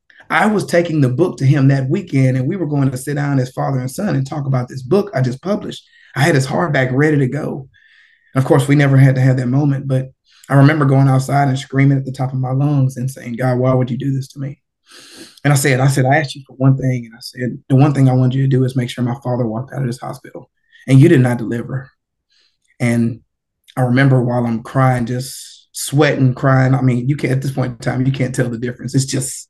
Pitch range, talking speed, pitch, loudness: 125-140 Hz, 265 wpm, 130 Hz, -16 LUFS